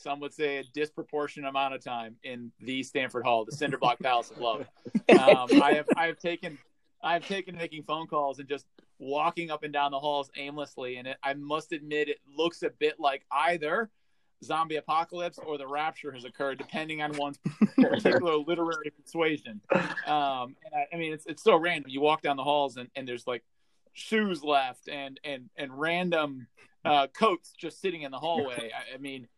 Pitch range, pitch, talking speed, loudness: 140-165 Hz, 150 Hz, 200 wpm, -29 LUFS